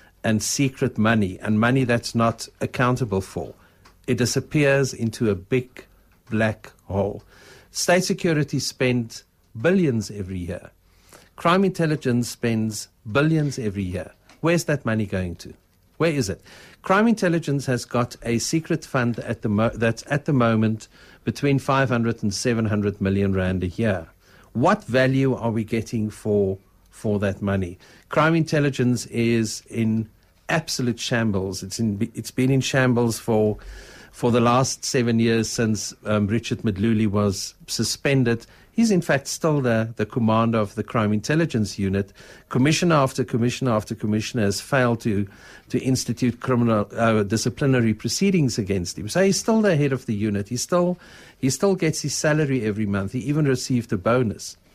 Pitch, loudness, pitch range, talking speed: 115 Hz, -22 LUFS, 105-135 Hz, 155 wpm